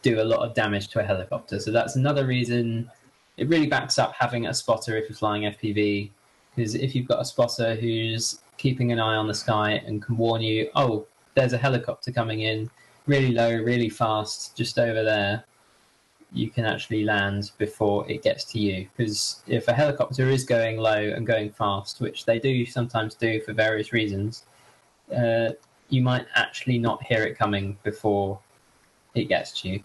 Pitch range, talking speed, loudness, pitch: 105-120 Hz, 185 wpm, -25 LUFS, 115 Hz